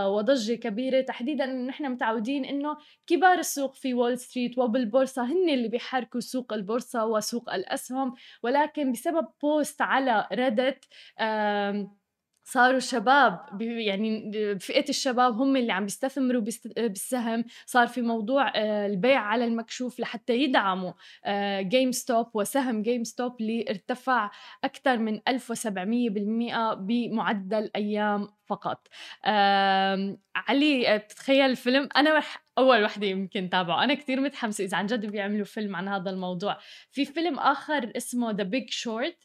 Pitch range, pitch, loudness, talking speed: 210-265 Hz, 240 Hz, -27 LUFS, 135 wpm